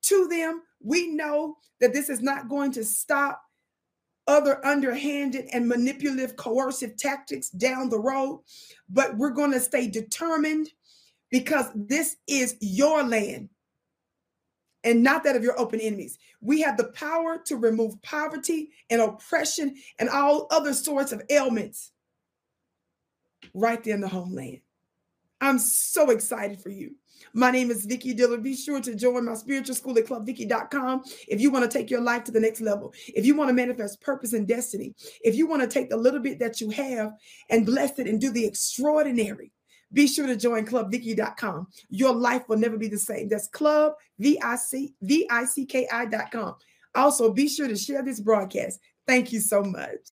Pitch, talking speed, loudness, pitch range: 255 Hz, 170 wpm, -25 LUFS, 225-285 Hz